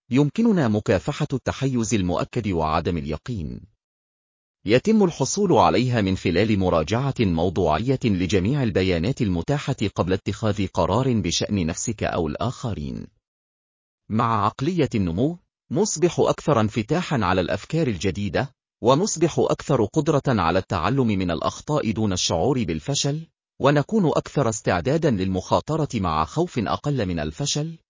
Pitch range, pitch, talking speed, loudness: 95-145 Hz, 115 Hz, 110 wpm, -22 LUFS